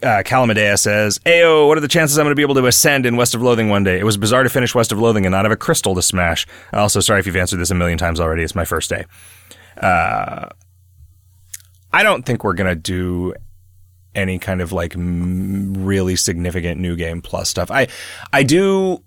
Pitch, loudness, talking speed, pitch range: 95 Hz, -16 LUFS, 225 wpm, 90-115 Hz